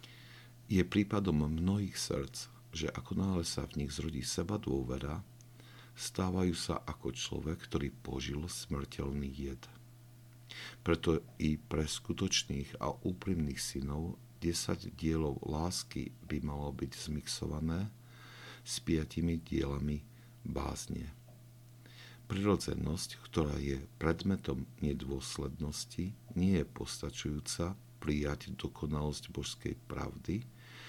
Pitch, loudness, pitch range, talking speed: 85 Hz, -37 LUFS, 70-115 Hz, 100 wpm